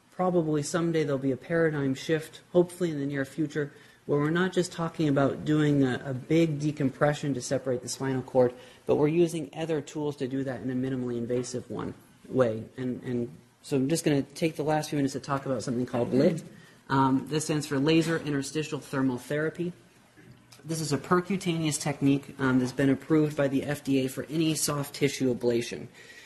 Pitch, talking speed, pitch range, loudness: 145 Hz, 195 wpm, 130-155 Hz, -28 LUFS